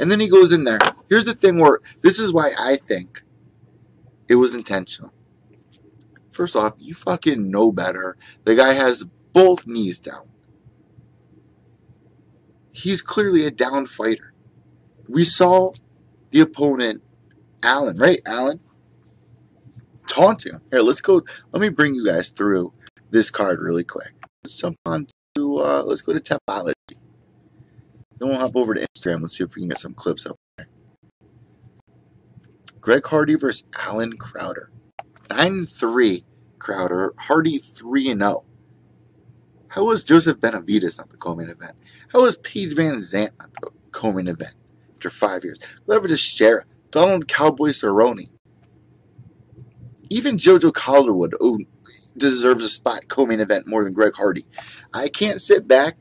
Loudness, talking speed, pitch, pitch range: -18 LUFS, 145 wpm, 135 Hz, 110-180 Hz